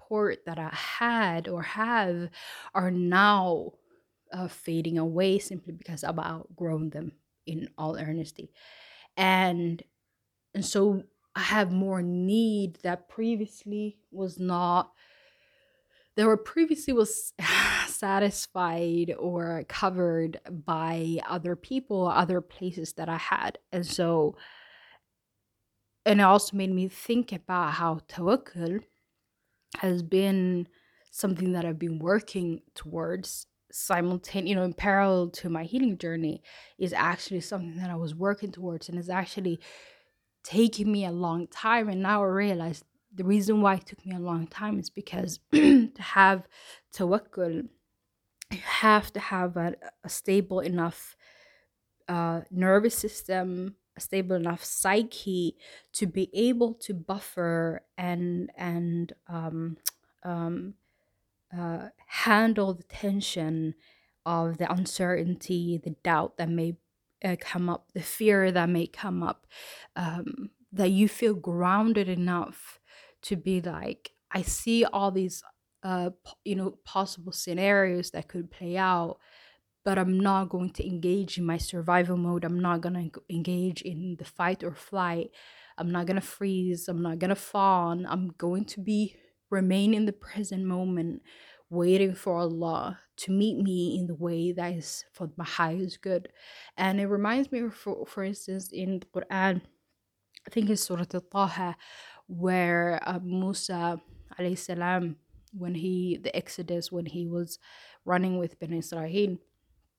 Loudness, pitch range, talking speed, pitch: -28 LUFS, 170-200 Hz, 140 wpm, 180 Hz